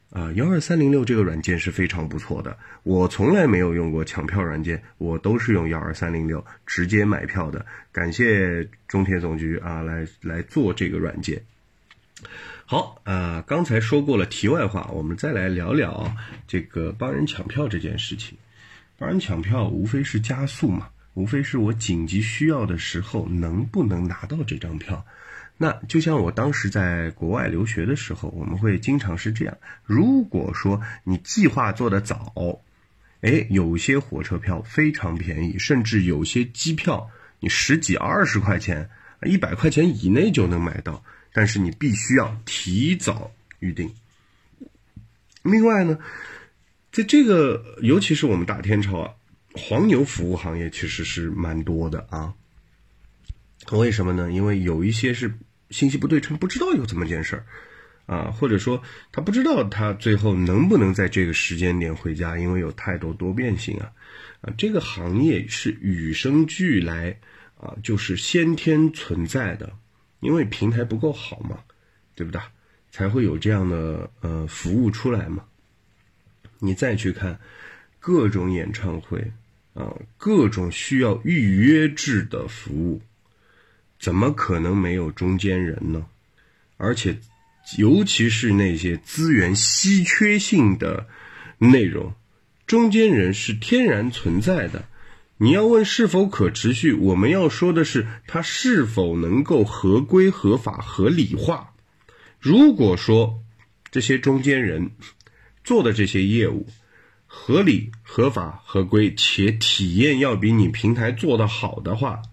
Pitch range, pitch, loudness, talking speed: 90-120 Hz, 105 Hz, -21 LUFS, 225 characters per minute